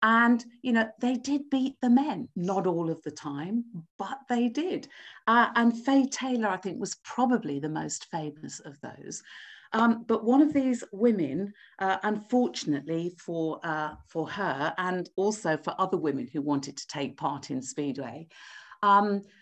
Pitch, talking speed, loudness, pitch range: 205 Hz, 165 wpm, -28 LUFS, 165-245 Hz